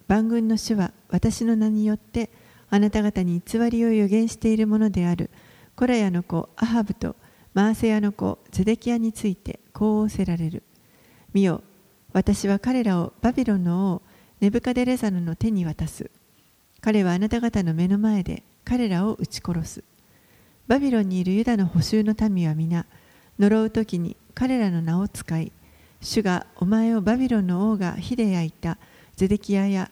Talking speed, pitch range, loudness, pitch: 305 characters per minute, 180-225 Hz, -23 LUFS, 210 Hz